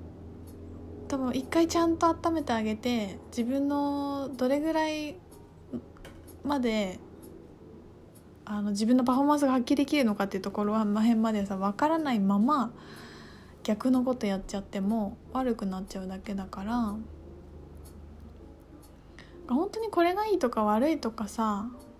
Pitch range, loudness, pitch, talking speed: 190-275 Hz, -29 LUFS, 220 Hz, 275 characters per minute